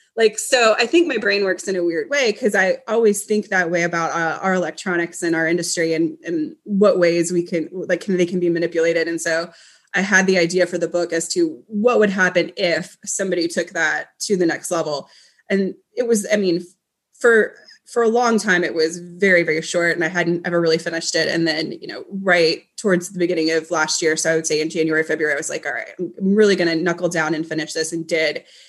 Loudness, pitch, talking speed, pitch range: -19 LUFS, 175 Hz, 240 wpm, 165-200 Hz